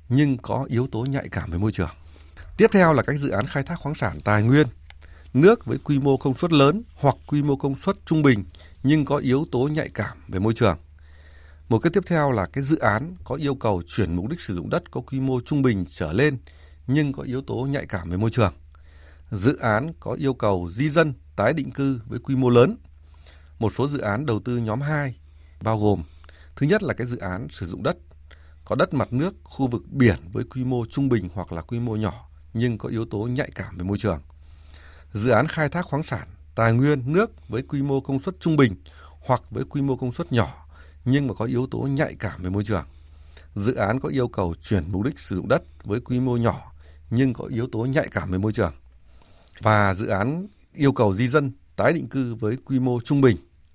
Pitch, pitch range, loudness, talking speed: 115 Hz, 85-135 Hz, -23 LUFS, 230 wpm